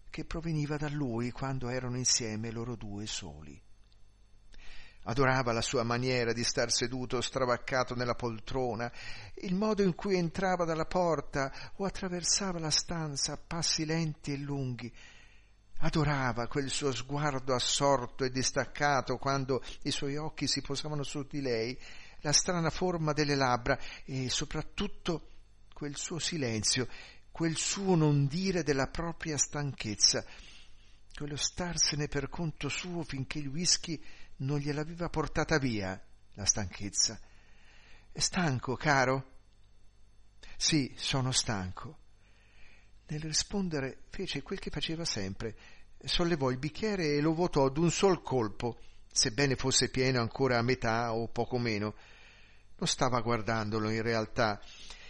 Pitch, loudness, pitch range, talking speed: 130 Hz, -32 LUFS, 115-155 Hz, 130 wpm